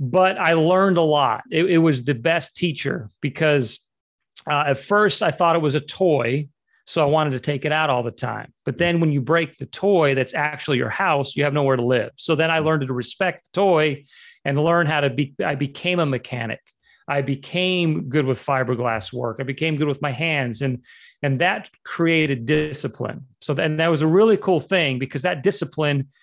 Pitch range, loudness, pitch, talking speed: 135-165 Hz, -21 LUFS, 150 Hz, 210 wpm